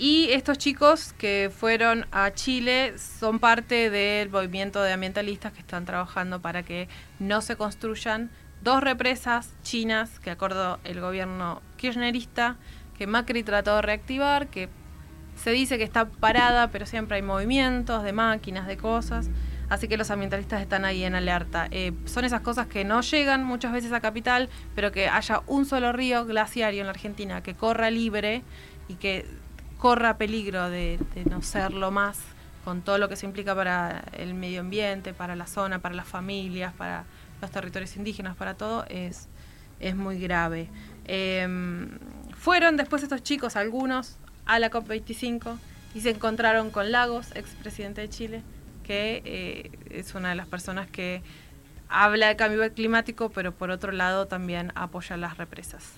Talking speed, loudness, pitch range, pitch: 165 wpm, -26 LUFS, 185-235 Hz, 210 Hz